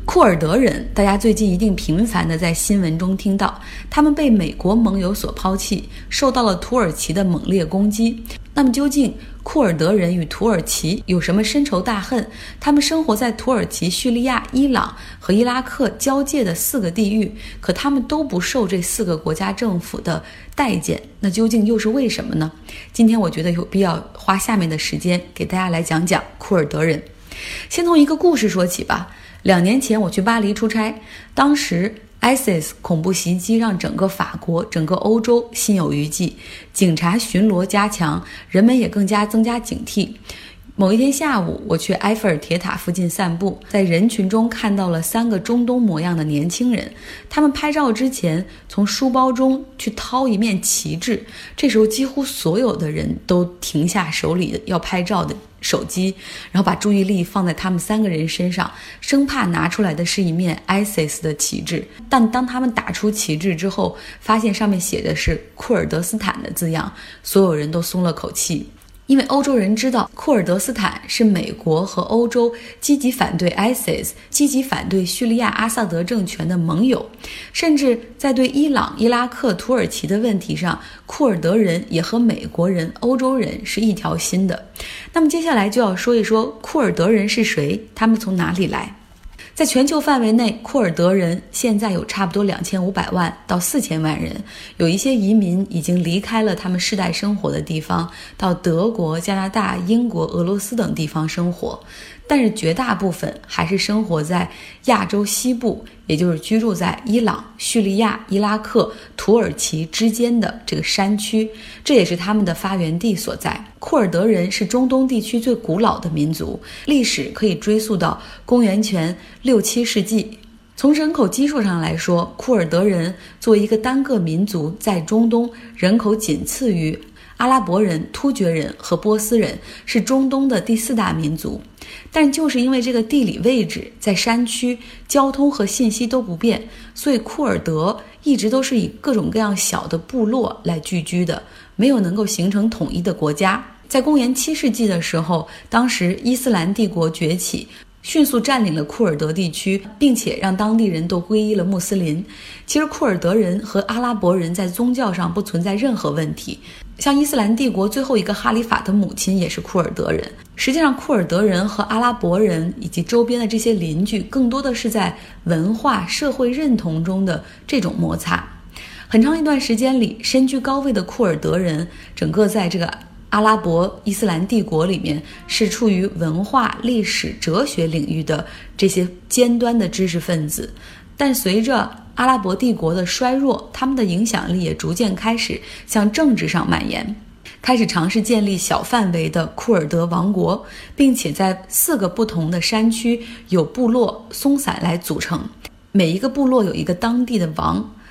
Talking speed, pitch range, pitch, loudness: 275 characters per minute, 180-240 Hz, 210 Hz, -18 LUFS